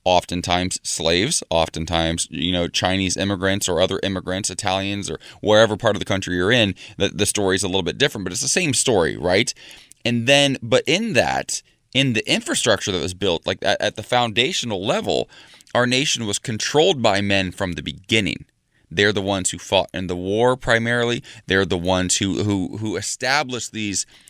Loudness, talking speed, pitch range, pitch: -20 LUFS, 190 wpm, 90-110 Hz, 100 Hz